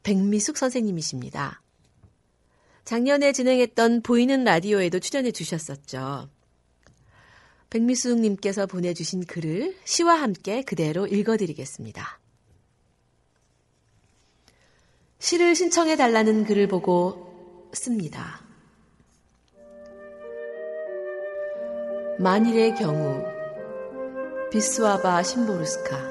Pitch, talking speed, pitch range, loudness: 200 Hz, 200 characters per minute, 165-245 Hz, -24 LUFS